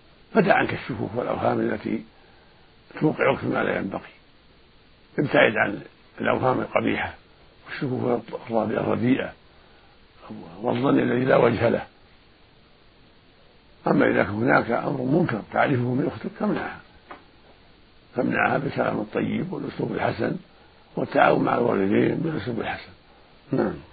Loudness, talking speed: -24 LUFS, 105 wpm